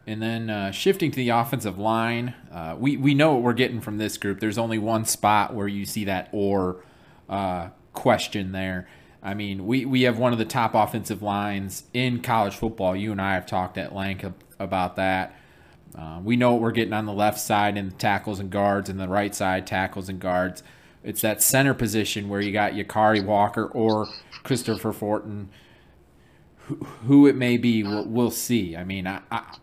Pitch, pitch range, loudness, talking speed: 105 Hz, 95-115 Hz, -24 LUFS, 205 wpm